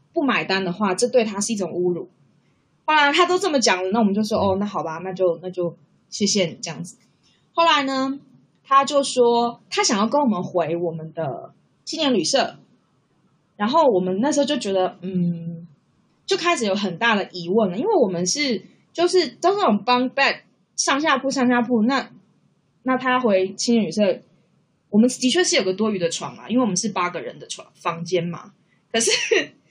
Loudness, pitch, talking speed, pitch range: -21 LUFS, 215 Hz, 280 characters per minute, 180-265 Hz